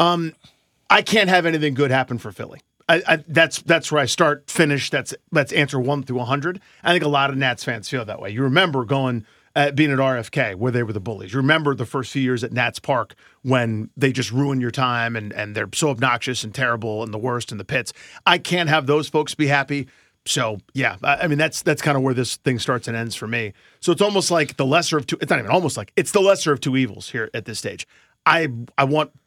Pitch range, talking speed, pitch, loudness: 120-155 Hz, 250 wpm, 135 Hz, -20 LUFS